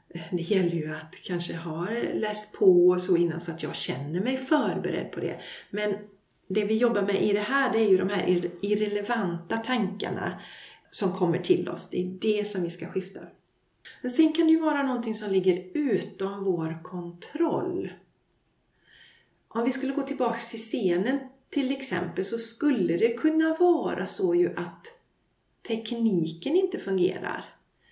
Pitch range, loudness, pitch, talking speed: 180-260 Hz, -26 LUFS, 205 Hz, 165 wpm